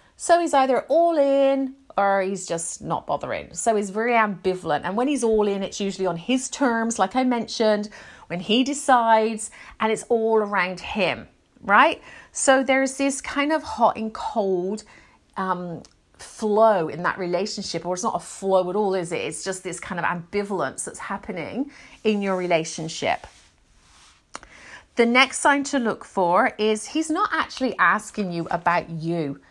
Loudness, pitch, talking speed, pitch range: -23 LUFS, 215 Hz, 170 wpm, 185-255 Hz